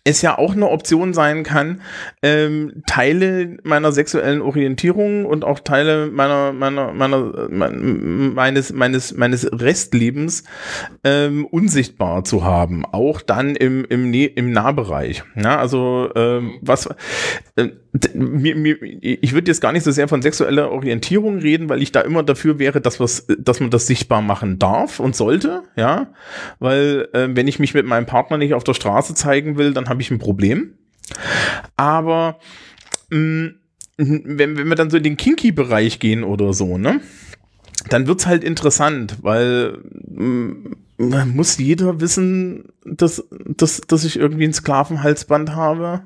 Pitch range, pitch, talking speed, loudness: 125-160 Hz, 145 Hz, 155 wpm, -17 LUFS